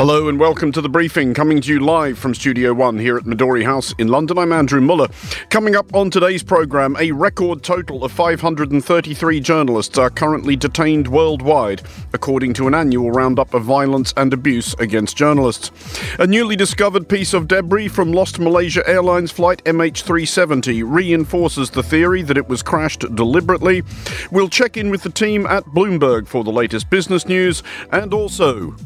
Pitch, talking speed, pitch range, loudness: 155 Hz, 175 wpm, 130-180 Hz, -16 LUFS